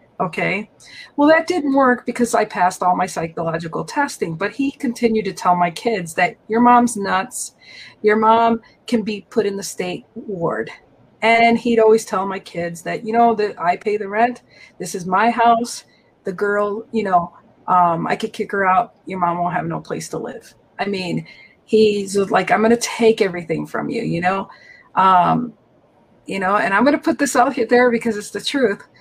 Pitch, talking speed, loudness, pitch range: 215 Hz, 200 wpm, -18 LUFS, 185-235 Hz